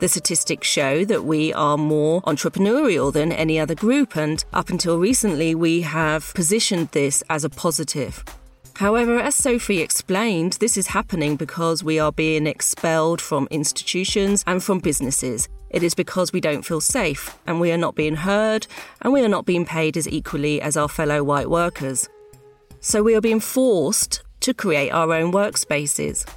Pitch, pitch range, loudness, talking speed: 165 Hz, 155-195 Hz, -20 LUFS, 175 wpm